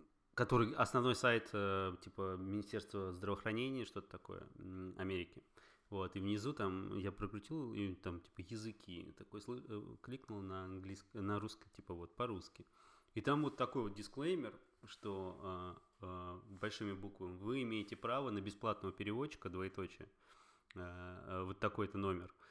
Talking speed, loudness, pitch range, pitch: 130 wpm, -43 LUFS, 95-110 Hz, 100 Hz